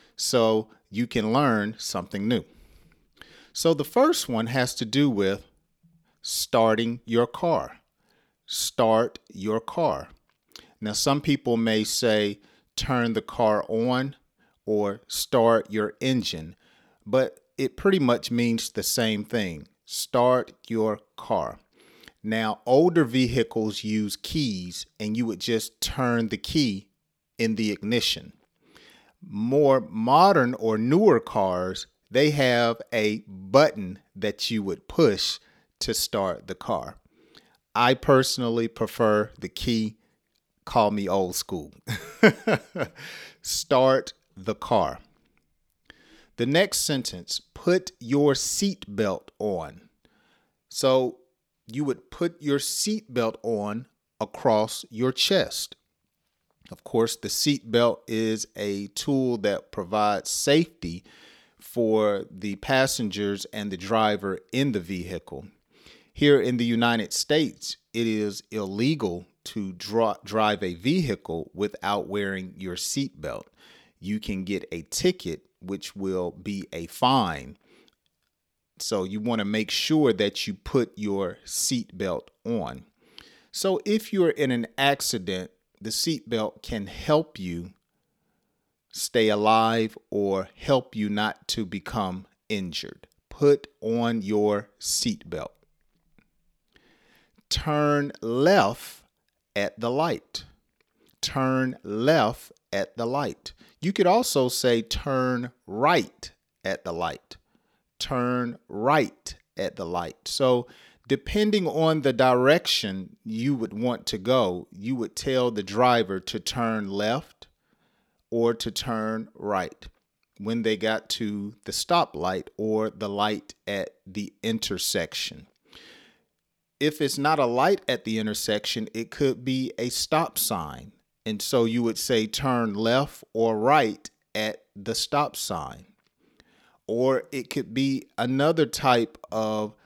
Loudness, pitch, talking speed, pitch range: -25 LUFS, 115 Hz, 120 wpm, 105-130 Hz